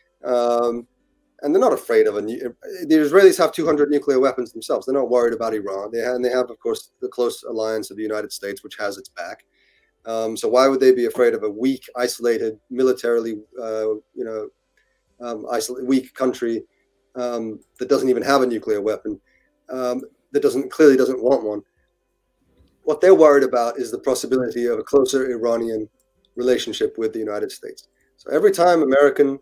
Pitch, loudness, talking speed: 130 Hz, -20 LUFS, 190 wpm